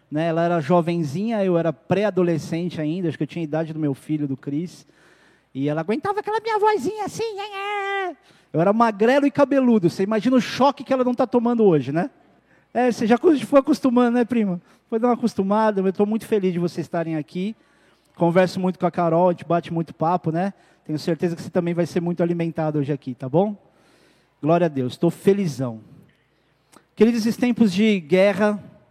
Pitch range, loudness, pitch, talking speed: 165-235 Hz, -21 LUFS, 185 Hz, 195 wpm